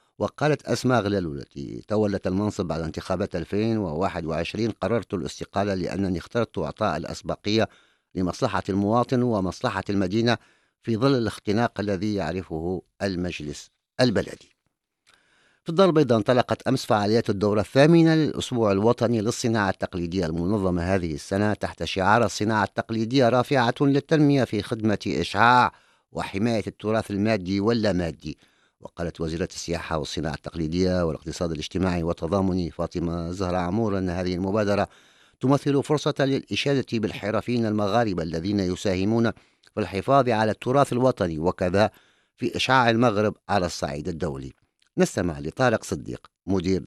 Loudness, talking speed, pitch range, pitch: -24 LUFS, 115 wpm, 90-115 Hz, 100 Hz